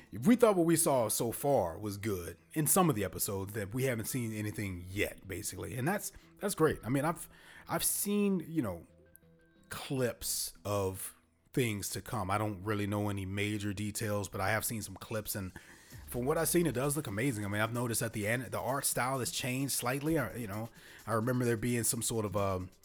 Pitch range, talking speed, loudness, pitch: 100-135 Hz, 225 wpm, -33 LUFS, 110 Hz